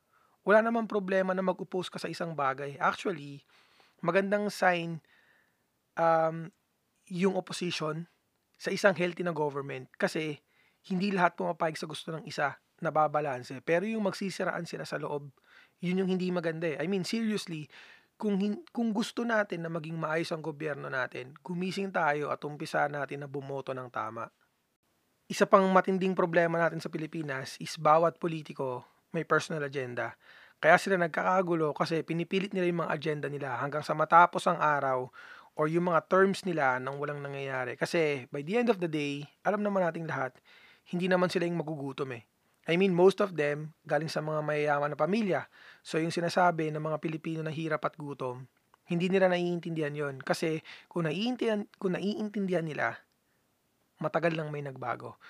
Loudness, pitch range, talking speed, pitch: -31 LUFS, 150-185 Hz, 165 wpm, 165 Hz